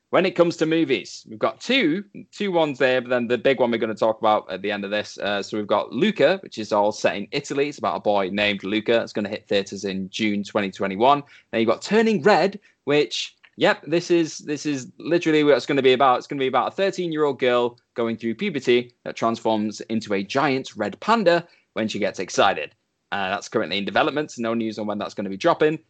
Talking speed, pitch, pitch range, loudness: 245 wpm, 125 Hz, 110-160 Hz, -22 LUFS